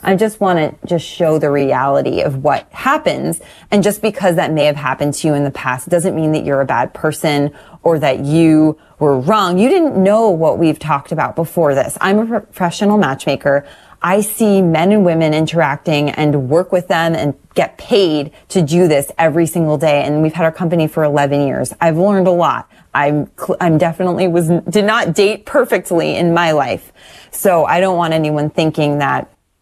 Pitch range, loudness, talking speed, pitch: 150-185 Hz, -14 LUFS, 195 wpm, 165 Hz